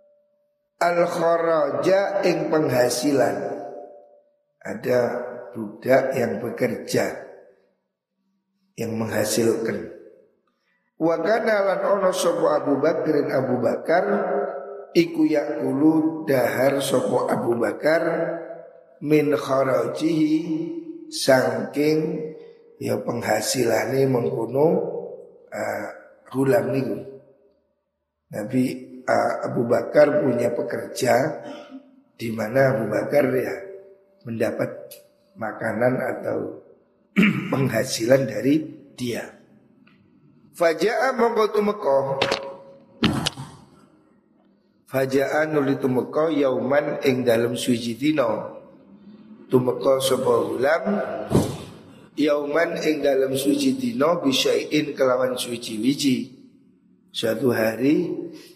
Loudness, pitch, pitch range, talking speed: -22 LUFS, 155 Hz, 135-210 Hz, 80 wpm